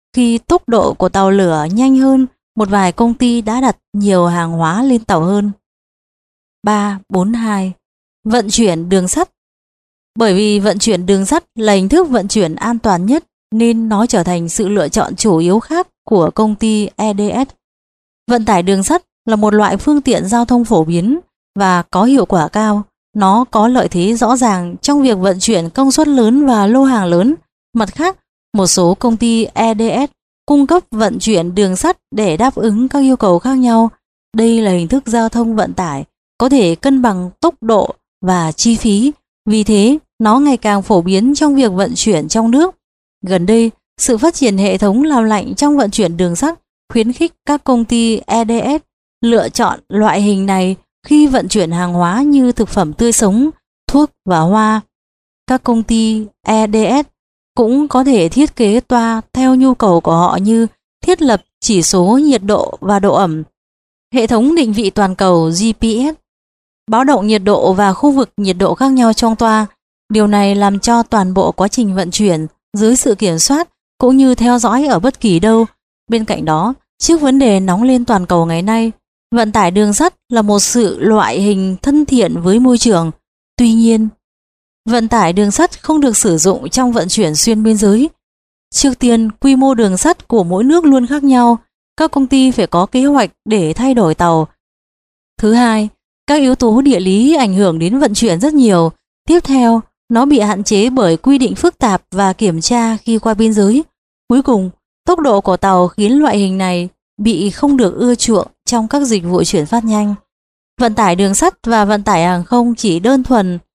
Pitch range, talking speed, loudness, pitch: 195-255 Hz, 200 wpm, -12 LUFS, 225 Hz